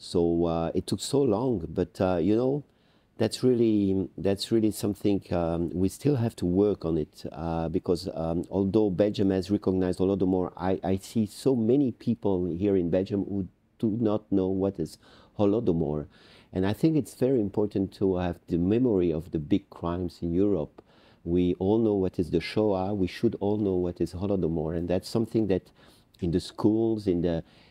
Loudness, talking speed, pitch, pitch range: -27 LUFS, 185 wpm, 95 Hz, 90-105 Hz